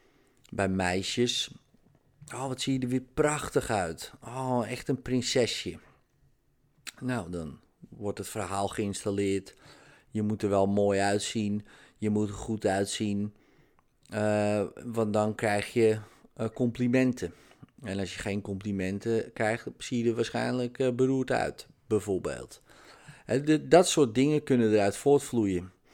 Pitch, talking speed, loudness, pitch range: 110 Hz, 130 wpm, -29 LUFS, 100-125 Hz